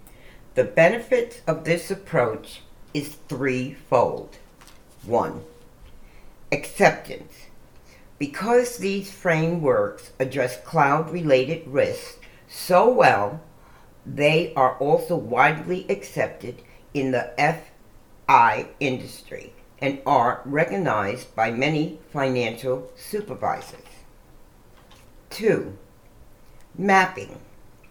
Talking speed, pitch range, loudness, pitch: 75 wpm, 130-190 Hz, -22 LUFS, 150 Hz